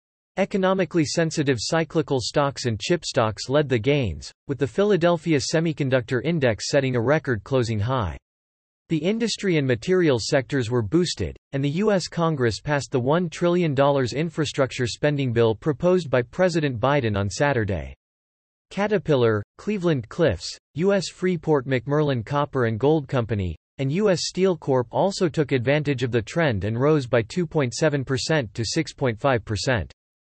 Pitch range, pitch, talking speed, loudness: 120-165 Hz, 140 Hz, 140 wpm, -23 LUFS